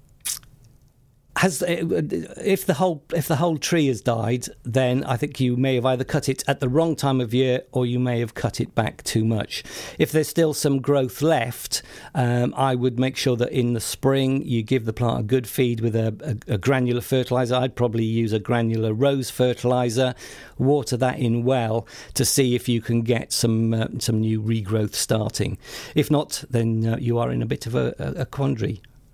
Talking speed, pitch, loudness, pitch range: 200 wpm, 125 Hz, -23 LUFS, 120-135 Hz